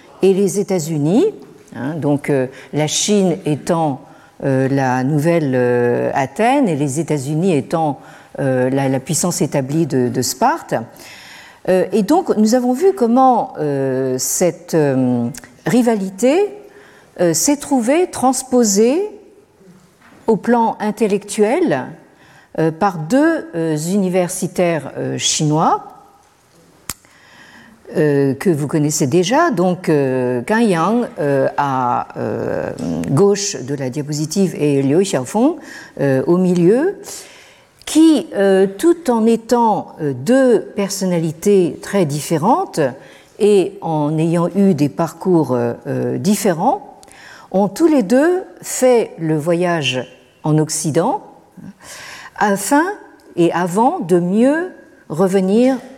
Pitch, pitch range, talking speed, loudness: 180 Hz, 150-240 Hz, 110 wpm, -16 LUFS